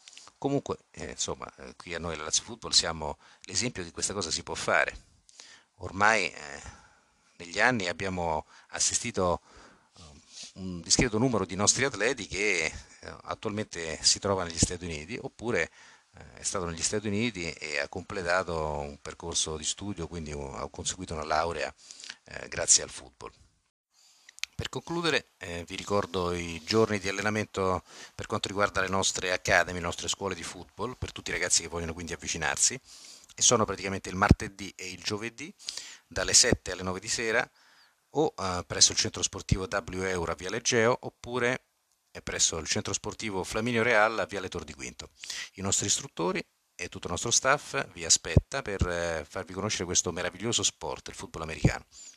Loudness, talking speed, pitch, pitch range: -29 LUFS, 170 wpm, 95 Hz, 85-105 Hz